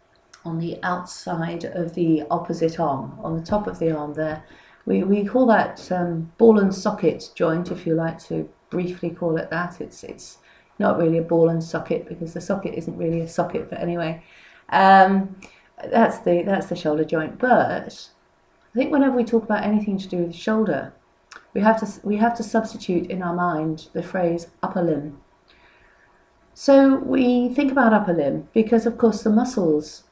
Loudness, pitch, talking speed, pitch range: -21 LUFS, 175 Hz, 185 wpm, 165-215 Hz